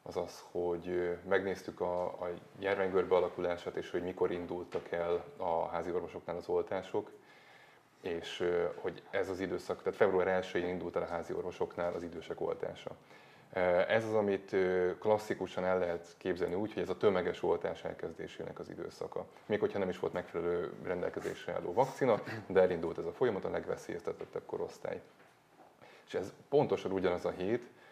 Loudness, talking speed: -36 LUFS, 155 wpm